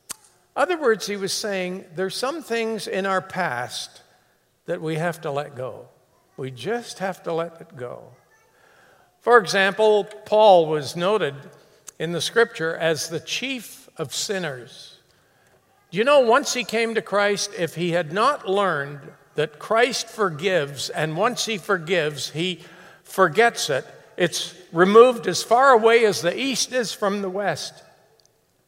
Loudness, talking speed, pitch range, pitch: -21 LUFS, 150 wpm, 165-220 Hz, 190 Hz